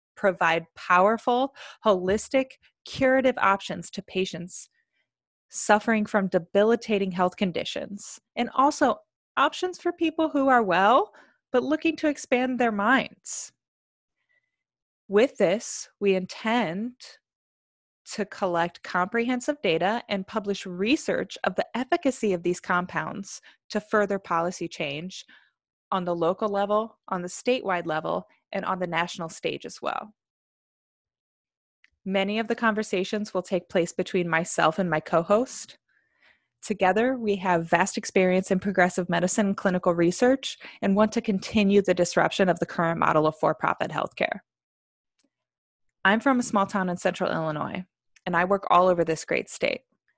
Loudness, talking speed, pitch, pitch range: -25 LUFS, 140 wpm, 200 Hz, 180-235 Hz